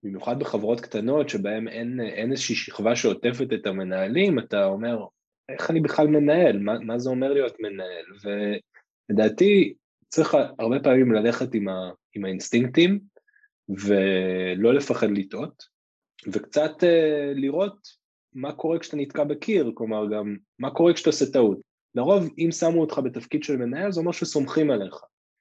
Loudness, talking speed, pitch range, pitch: -24 LUFS, 140 wpm, 110-155 Hz, 130 Hz